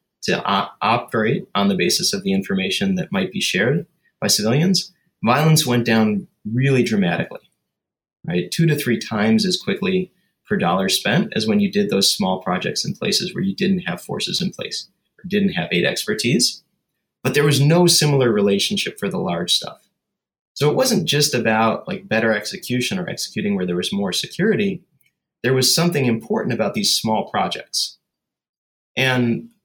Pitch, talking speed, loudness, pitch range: 180 Hz, 170 wpm, -19 LUFS, 130-200 Hz